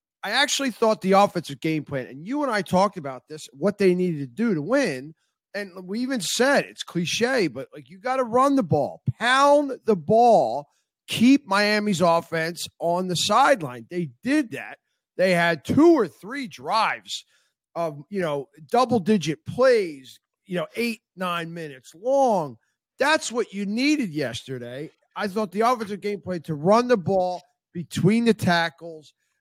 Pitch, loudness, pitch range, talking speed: 195 Hz, -23 LUFS, 165-240 Hz, 170 wpm